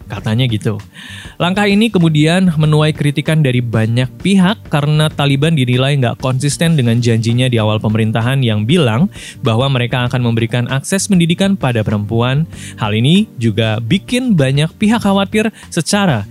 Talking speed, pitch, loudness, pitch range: 140 wpm, 135 Hz, -14 LUFS, 115-170 Hz